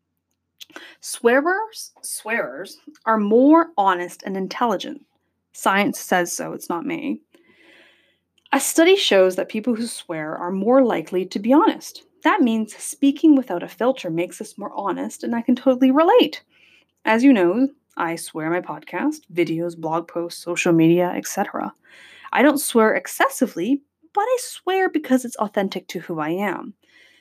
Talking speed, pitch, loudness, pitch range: 150 wpm, 230 Hz, -20 LUFS, 180-285 Hz